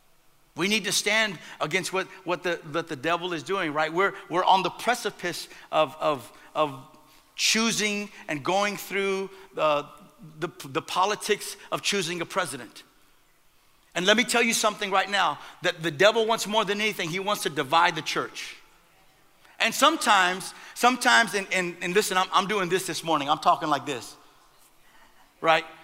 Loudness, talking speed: -25 LUFS, 170 wpm